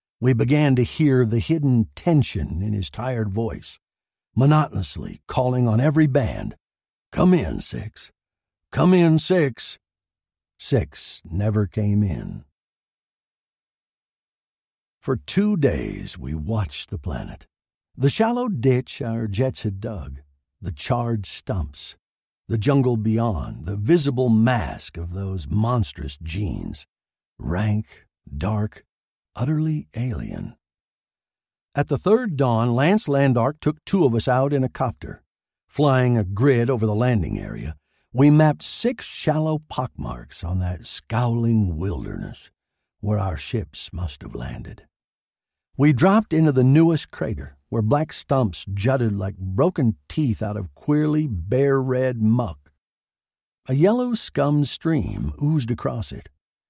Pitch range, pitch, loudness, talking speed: 95-140 Hz, 115 Hz, -22 LUFS, 125 wpm